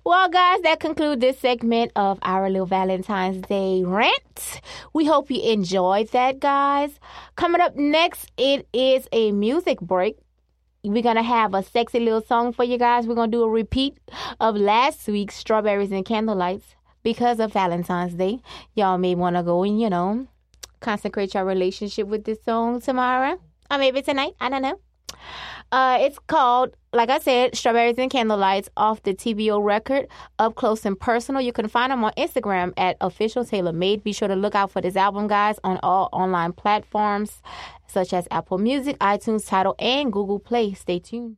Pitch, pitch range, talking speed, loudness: 220 Hz, 195-255 Hz, 180 wpm, -22 LUFS